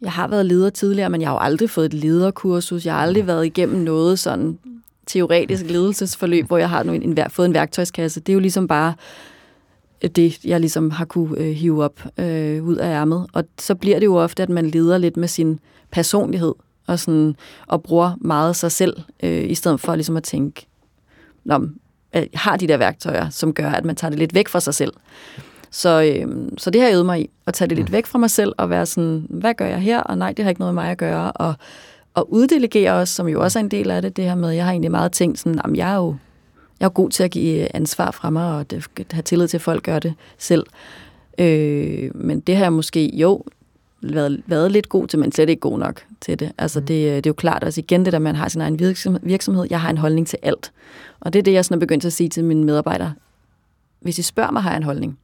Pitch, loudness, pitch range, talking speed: 170 Hz, -19 LUFS, 155-180 Hz, 250 wpm